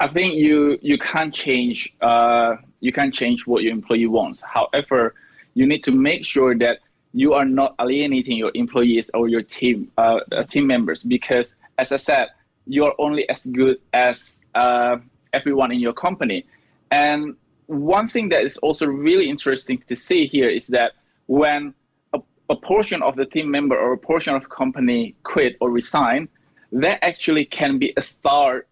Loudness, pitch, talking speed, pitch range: -19 LUFS, 135 Hz, 175 wpm, 125-160 Hz